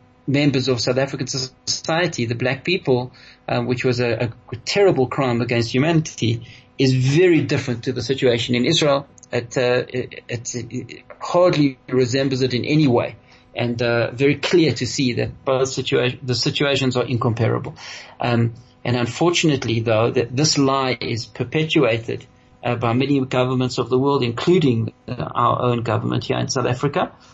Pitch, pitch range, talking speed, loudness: 125 Hz, 120-140 Hz, 160 wpm, -20 LUFS